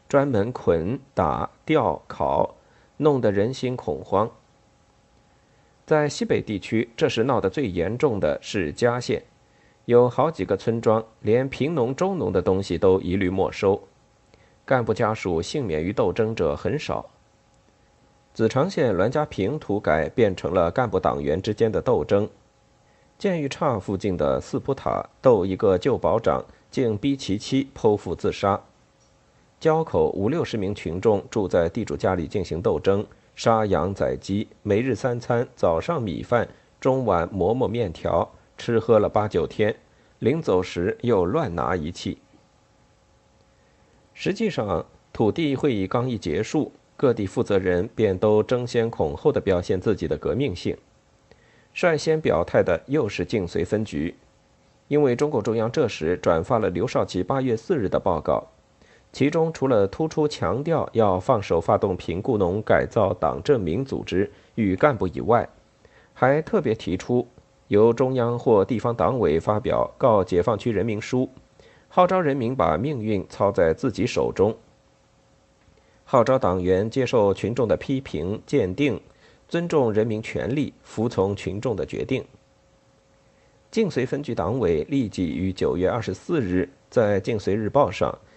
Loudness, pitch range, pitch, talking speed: -23 LUFS, 100-135 Hz, 115 Hz, 220 characters per minute